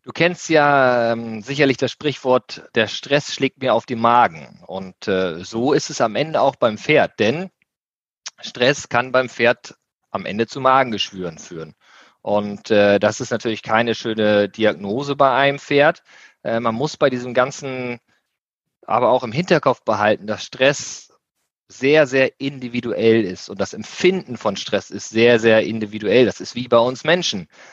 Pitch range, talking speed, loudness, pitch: 110-140 Hz, 165 wpm, -18 LUFS, 125 Hz